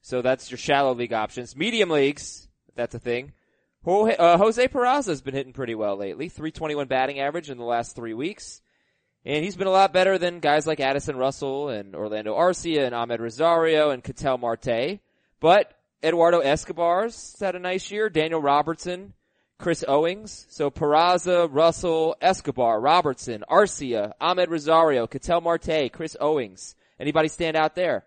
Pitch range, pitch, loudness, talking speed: 130-170 Hz, 155 Hz, -23 LUFS, 160 wpm